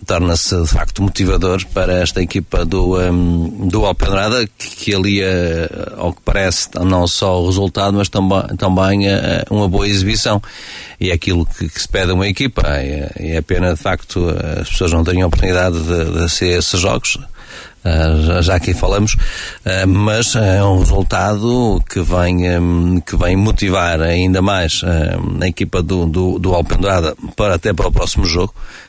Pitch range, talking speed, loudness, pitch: 85-100 Hz, 165 wpm, -15 LUFS, 90 Hz